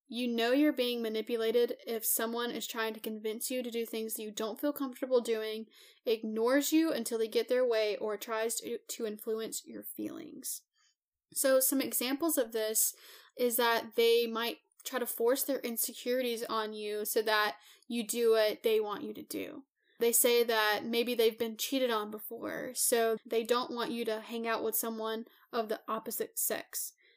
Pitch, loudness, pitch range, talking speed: 235 Hz, -32 LUFS, 225-260 Hz, 185 wpm